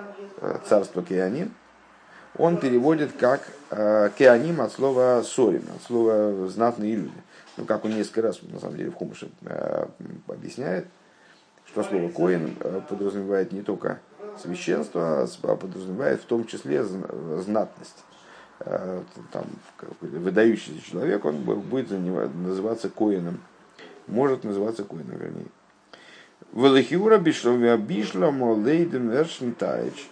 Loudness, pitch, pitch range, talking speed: -24 LUFS, 115 Hz, 100-130 Hz, 110 wpm